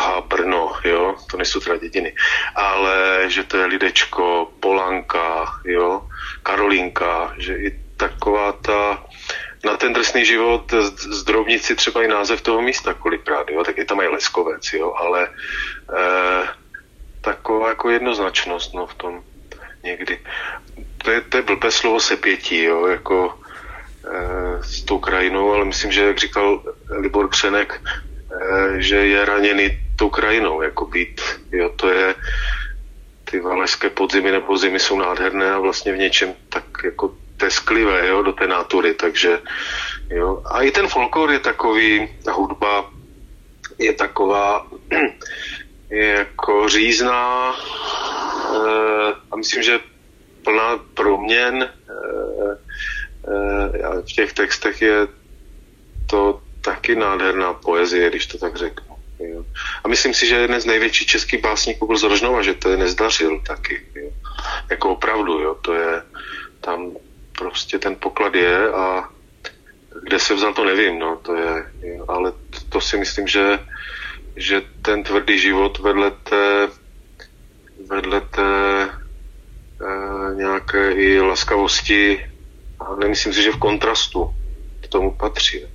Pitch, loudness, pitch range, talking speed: 100 Hz, -18 LUFS, 90-110 Hz, 135 wpm